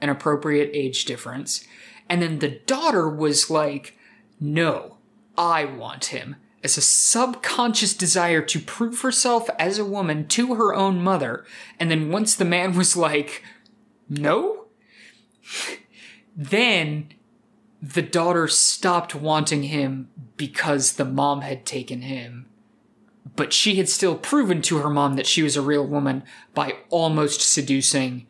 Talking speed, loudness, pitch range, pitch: 140 wpm, -21 LUFS, 145-210 Hz, 160 Hz